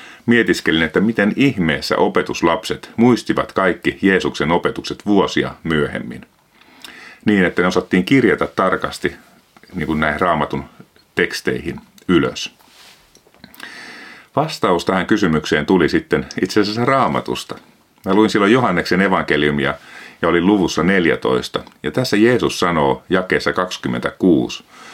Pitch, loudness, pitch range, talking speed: 95 Hz, -17 LUFS, 70-110 Hz, 110 wpm